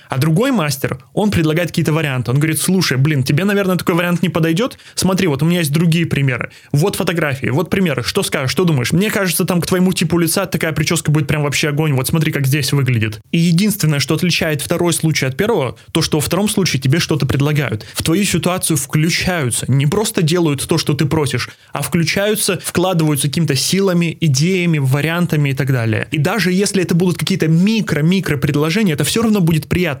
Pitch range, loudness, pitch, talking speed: 145-185 Hz, -16 LUFS, 165 Hz, 200 wpm